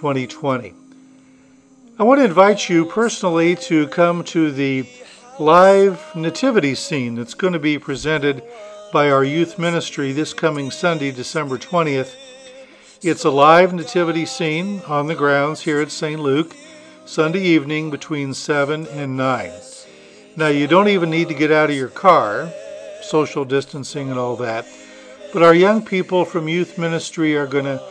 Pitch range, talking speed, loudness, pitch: 140-185 Hz, 155 wpm, -17 LUFS, 160 Hz